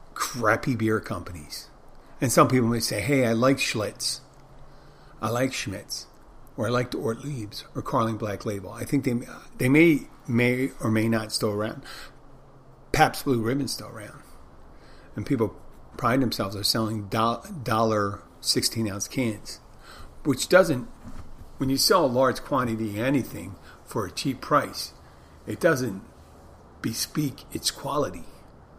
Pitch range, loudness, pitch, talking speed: 105-130 Hz, -25 LUFS, 115 Hz, 145 wpm